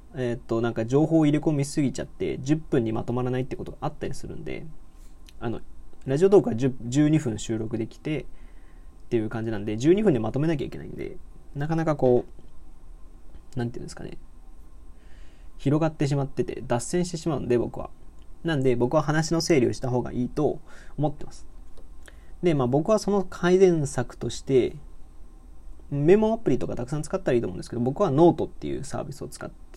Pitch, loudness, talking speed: 125 Hz, -25 LUFS, 385 characters per minute